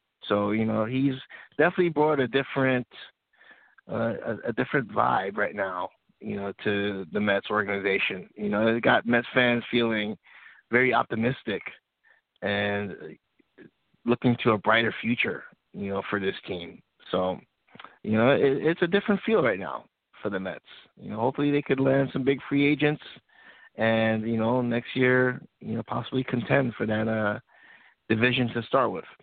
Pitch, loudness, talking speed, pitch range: 120 Hz, -26 LUFS, 165 wpm, 105-135 Hz